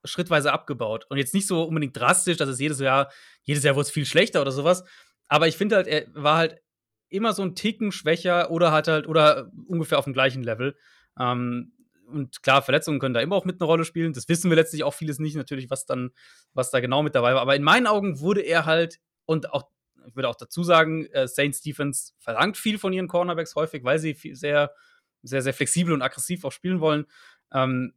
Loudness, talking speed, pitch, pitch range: -23 LUFS, 220 wpm, 155 Hz, 140-175 Hz